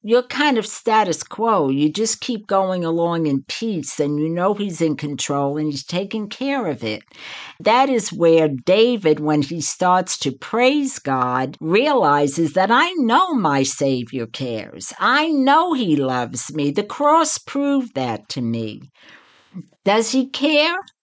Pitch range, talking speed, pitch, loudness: 145-240 Hz, 155 wpm, 180 Hz, -19 LUFS